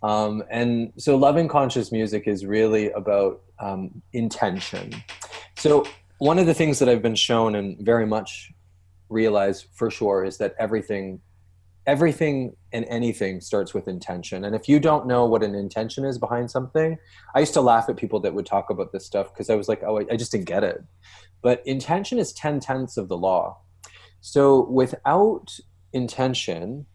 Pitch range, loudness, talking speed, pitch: 95-130 Hz, -23 LUFS, 180 wpm, 110 Hz